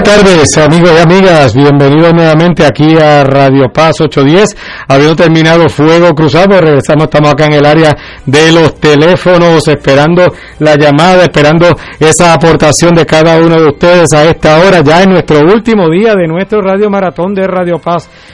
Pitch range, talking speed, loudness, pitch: 150-175 Hz, 165 wpm, -5 LUFS, 160 Hz